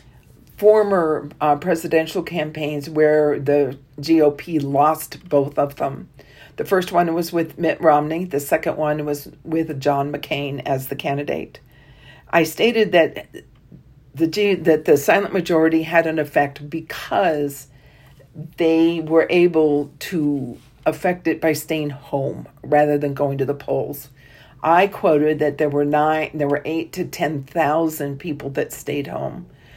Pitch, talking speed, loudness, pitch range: 150 Hz, 145 wpm, -20 LUFS, 140-165 Hz